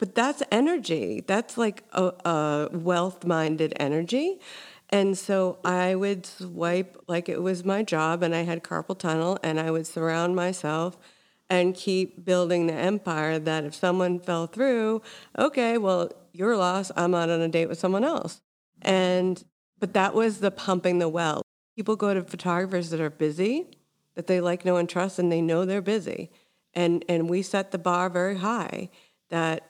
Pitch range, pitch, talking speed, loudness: 170-195 Hz, 180 Hz, 175 wpm, -26 LUFS